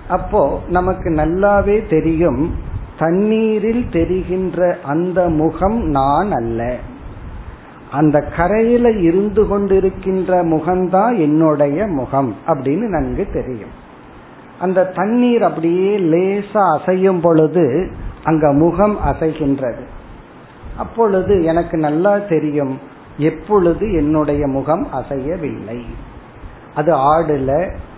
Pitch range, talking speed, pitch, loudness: 140-190 Hz, 85 wpm, 160 Hz, -16 LUFS